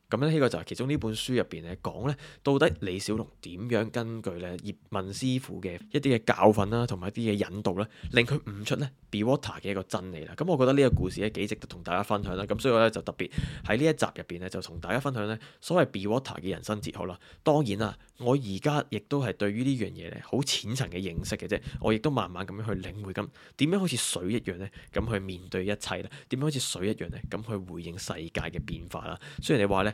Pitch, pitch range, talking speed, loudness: 105 Hz, 95-125 Hz, 380 characters per minute, -30 LUFS